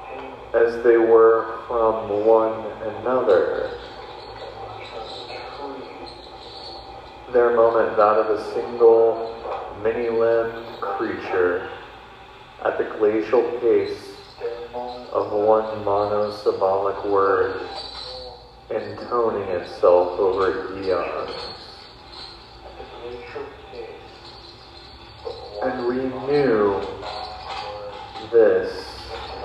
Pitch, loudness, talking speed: 135 Hz, -21 LUFS, 65 wpm